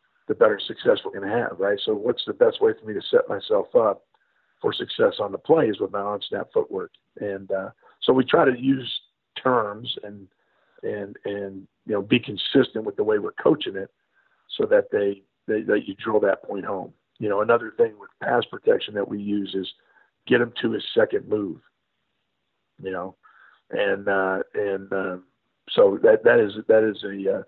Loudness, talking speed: -23 LUFS, 200 wpm